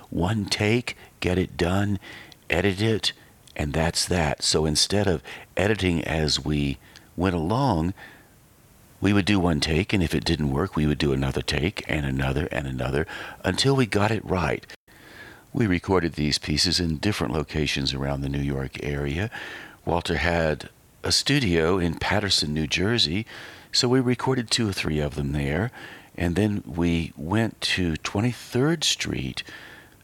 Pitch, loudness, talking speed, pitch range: 85 Hz, -24 LUFS, 155 wpm, 75-100 Hz